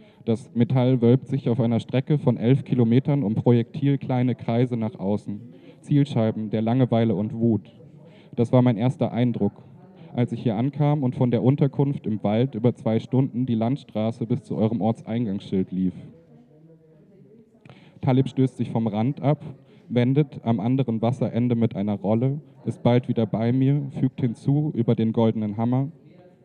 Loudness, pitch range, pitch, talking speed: -23 LUFS, 115-140 Hz, 125 Hz, 160 wpm